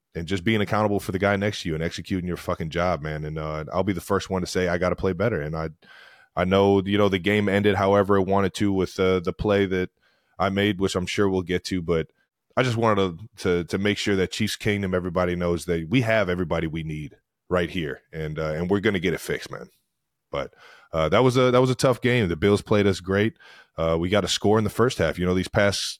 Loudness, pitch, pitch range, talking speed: -24 LUFS, 95 Hz, 90-105 Hz, 265 wpm